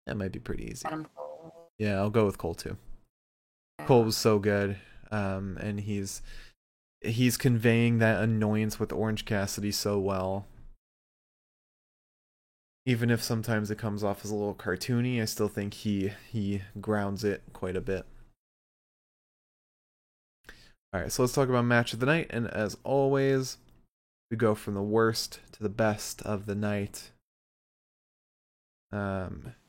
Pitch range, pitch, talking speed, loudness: 100-115 Hz, 105 Hz, 145 wpm, -29 LUFS